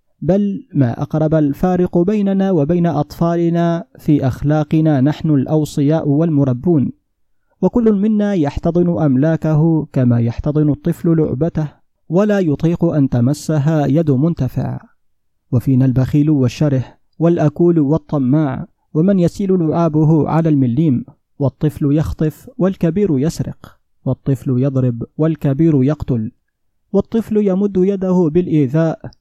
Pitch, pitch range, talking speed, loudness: 155 Hz, 140-170 Hz, 100 wpm, -16 LUFS